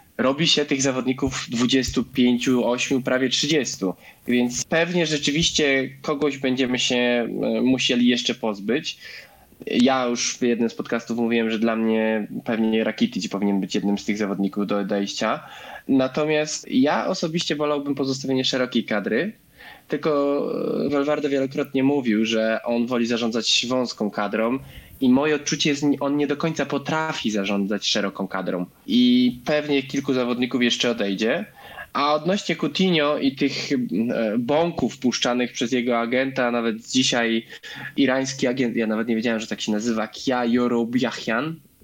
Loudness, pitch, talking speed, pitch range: -22 LUFS, 130 Hz, 140 wpm, 115-145 Hz